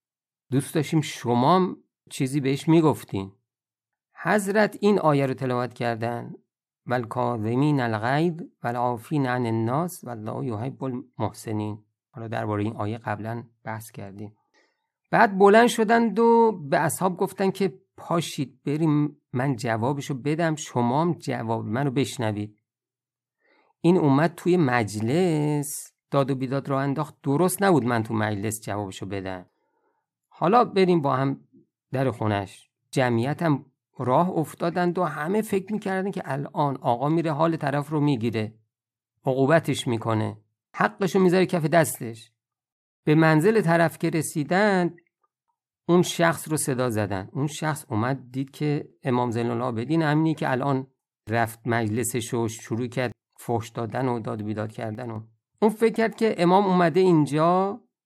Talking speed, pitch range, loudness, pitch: 135 wpm, 115-170 Hz, -24 LUFS, 140 Hz